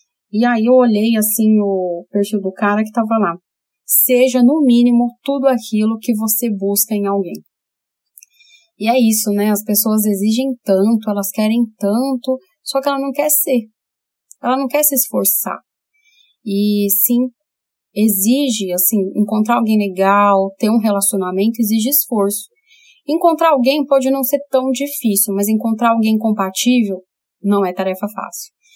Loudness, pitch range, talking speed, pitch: -15 LUFS, 205-265 Hz, 150 wpm, 225 Hz